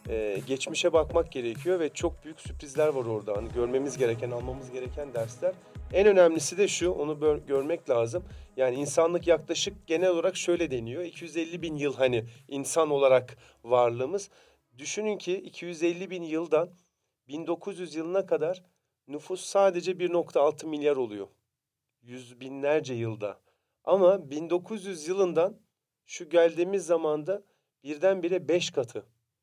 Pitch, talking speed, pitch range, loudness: 160 Hz, 125 wpm, 130-175 Hz, -28 LUFS